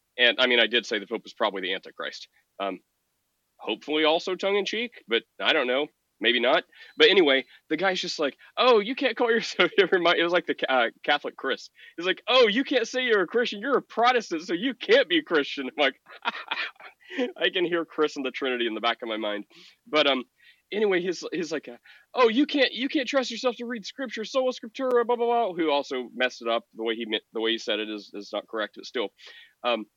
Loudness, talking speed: -25 LUFS, 235 wpm